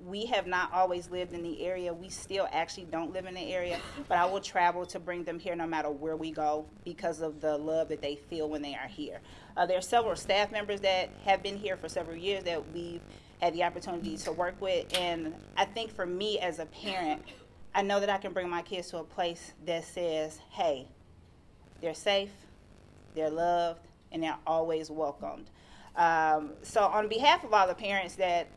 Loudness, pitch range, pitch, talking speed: -32 LUFS, 160-185 Hz, 175 Hz, 210 wpm